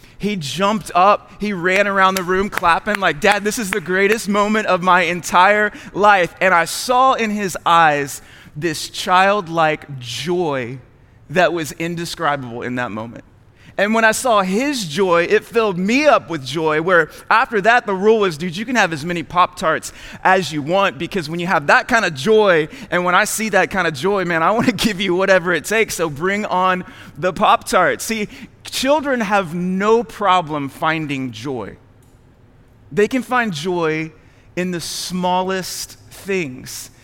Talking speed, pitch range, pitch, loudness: 180 wpm, 155-205 Hz, 180 Hz, -17 LUFS